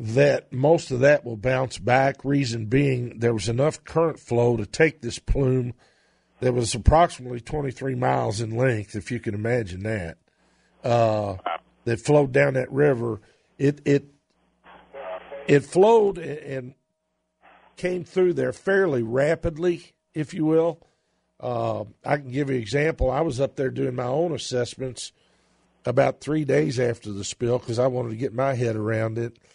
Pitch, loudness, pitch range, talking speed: 130 Hz, -24 LUFS, 120-150 Hz, 160 wpm